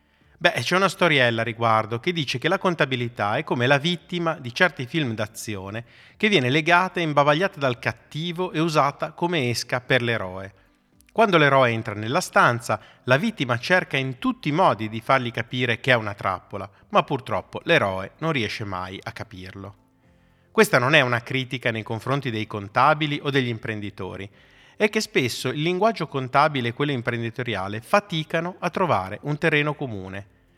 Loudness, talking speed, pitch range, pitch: -22 LUFS, 170 wpm, 110-160 Hz, 130 Hz